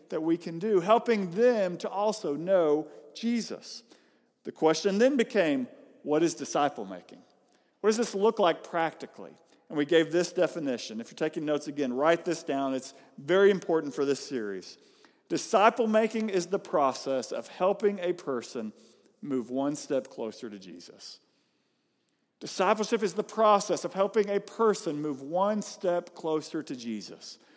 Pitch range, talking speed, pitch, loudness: 150-215 Hz, 155 wpm, 180 Hz, -28 LUFS